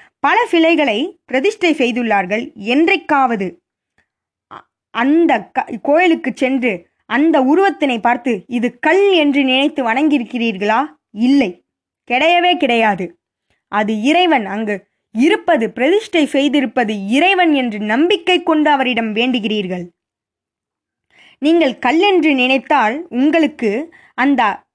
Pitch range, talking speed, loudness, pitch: 235-325 Hz, 90 wpm, -15 LUFS, 275 Hz